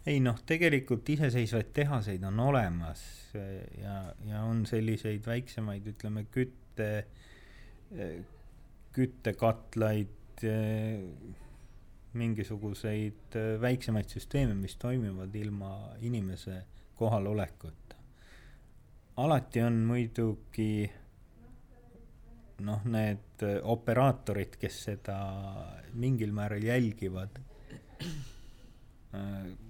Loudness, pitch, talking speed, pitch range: -34 LUFS, 110 Hz, 75 wpm, 100-120 Hz